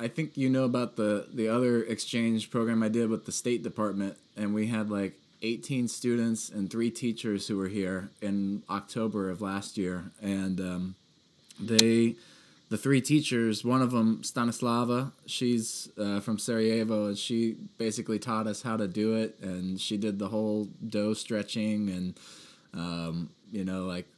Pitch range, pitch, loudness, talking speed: 100-115 Hz, 110 Hz, -30 LUFS, 170 wpm